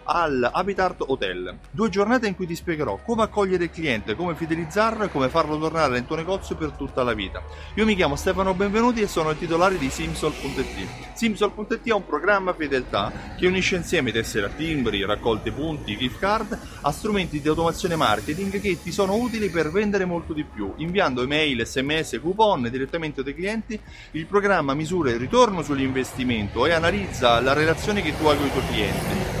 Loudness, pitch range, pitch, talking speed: -23 LUFS, 135-200 Hz, 165 Hz, 185 wpm